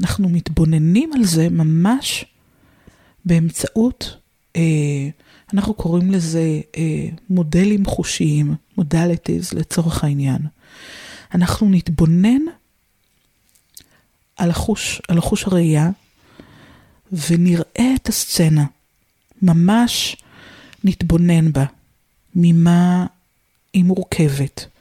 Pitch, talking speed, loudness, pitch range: 170 Hz, 75 wpm, -17 LUFS, 160-195 Hz